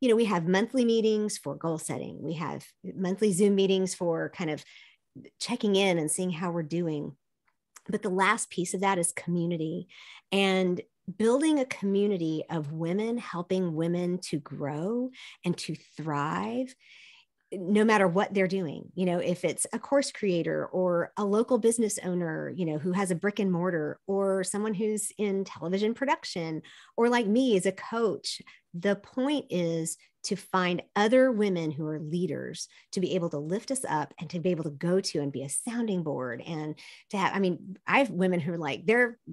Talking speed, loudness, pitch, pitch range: 190 wpm, -29 LUFS, 185 Hz, 170-210 Hz